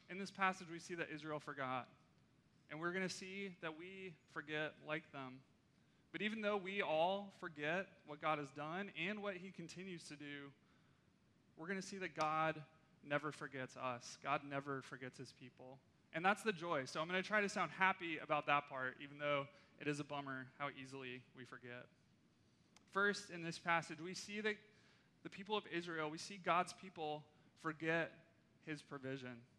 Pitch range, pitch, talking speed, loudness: 140-185 Hz, 155 Hz, 185 wpm, -44 LUFS